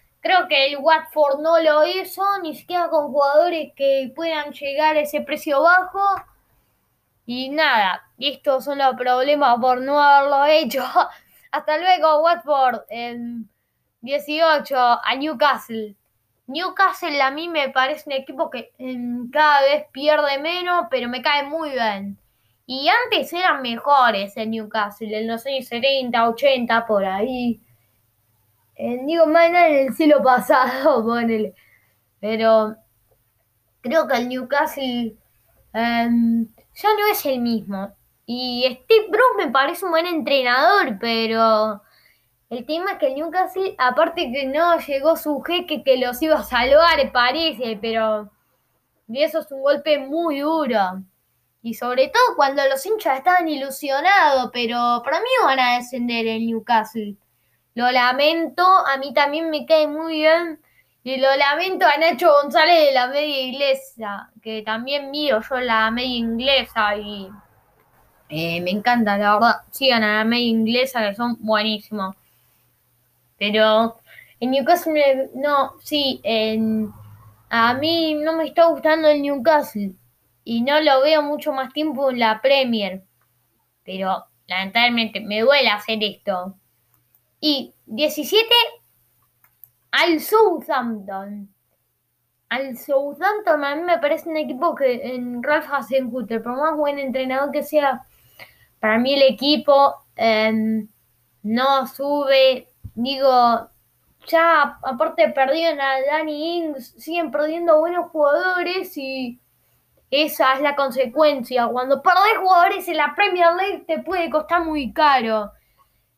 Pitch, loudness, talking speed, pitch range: 270 Hz, -19 LUFS, 135 wpm, 230-310 Hz